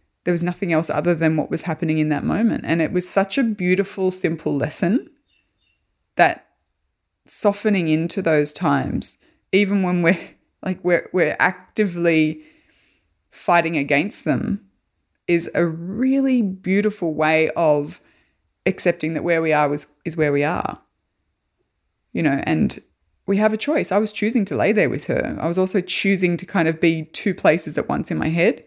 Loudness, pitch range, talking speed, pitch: -20 LUFS, 155-195 Hz, 170 wpm, 175 Hz